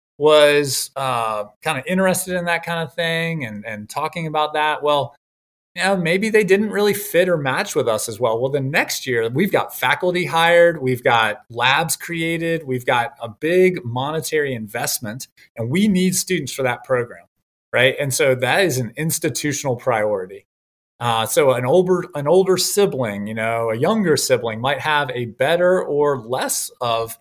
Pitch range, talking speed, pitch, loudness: 125-175 Hz, 180 wpm, 150 Hz, -19 LUFS